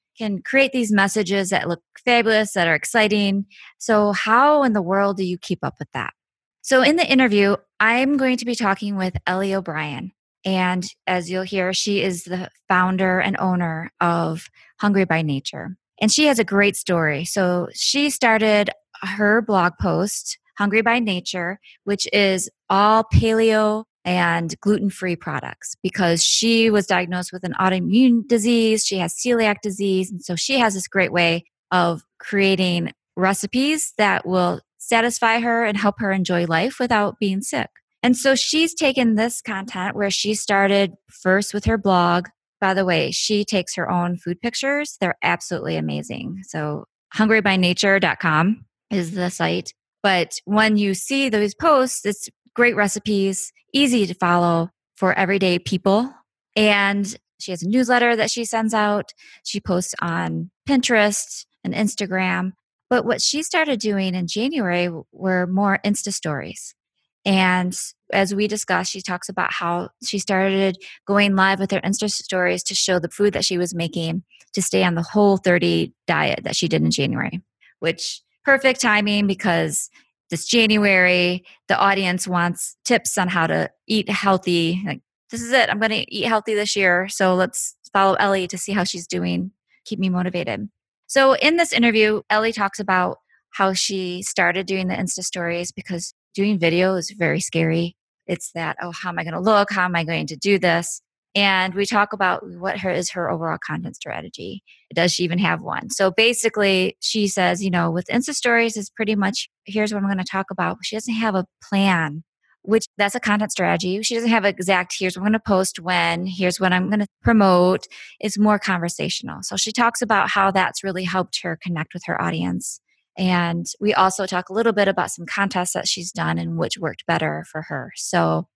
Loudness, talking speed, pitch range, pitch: -20 LUFS, 180 wpm, 180-215 Hz, 195 Hz